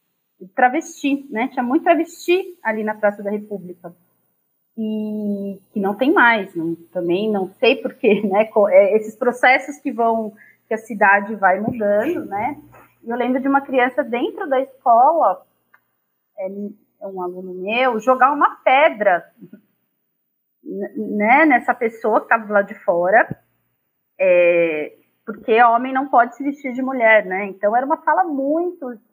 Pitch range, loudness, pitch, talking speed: 205-270 Hz, -18 LUFS, 230 Hz, 140 wpm